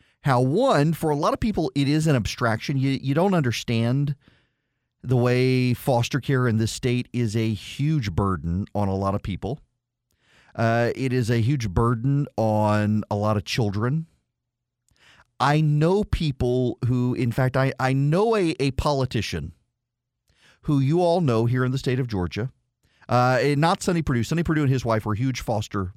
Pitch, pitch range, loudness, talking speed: 125 Hz, 115-140 Hz, -23 LUFS, 180 wpm